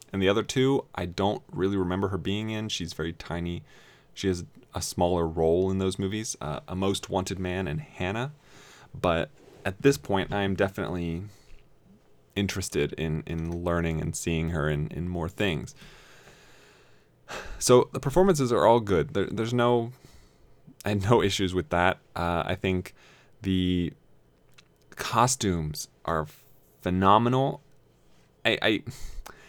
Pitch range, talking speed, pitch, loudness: 85-115 Hz, 145 wpm, 95 Hz, -27 LUFS